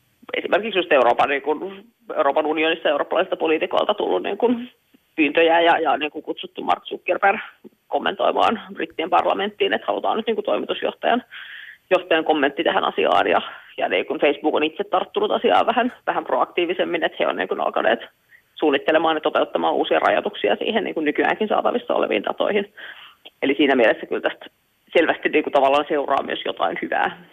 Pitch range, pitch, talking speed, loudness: 155-230 Hz, 180 Hz, 165 wpm, -21 LUFS